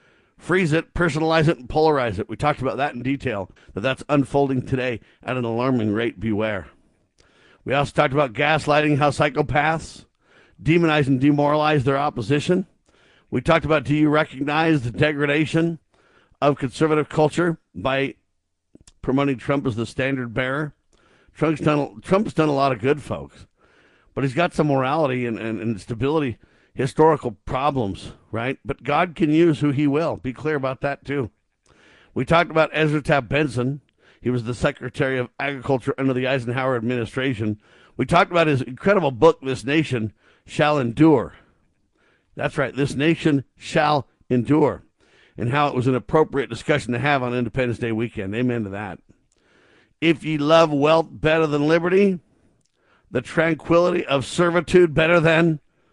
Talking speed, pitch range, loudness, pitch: 155 wpm, 125-155 Hz, -21 LUFS, 140 Hz